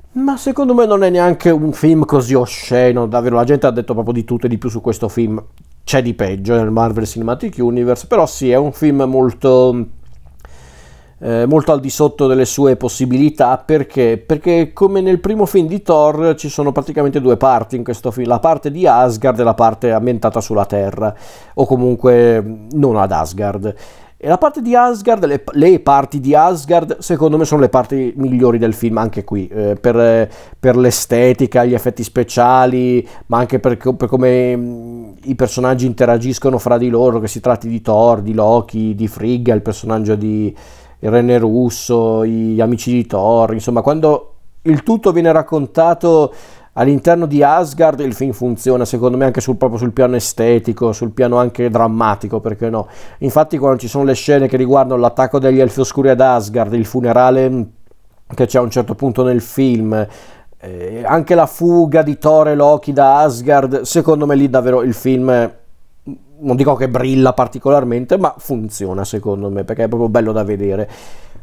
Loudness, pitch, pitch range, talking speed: -13 LUFS, 125 Hz, 115-140 Hz, 180 wpm